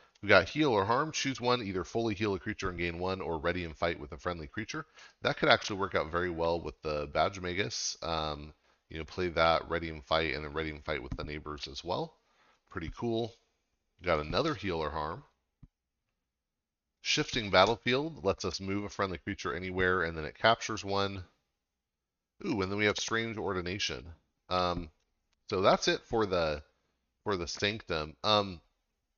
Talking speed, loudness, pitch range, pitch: 185 wpm, -32 LUFS, 80-100 Hz, 90 Hz